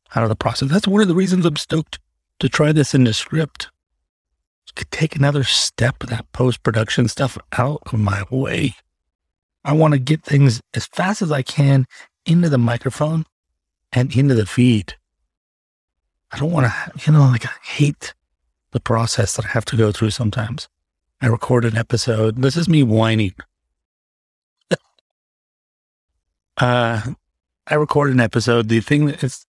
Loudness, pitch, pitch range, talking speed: -18 LUFS, 120 Hz, 85-140 Hz, 165 wpm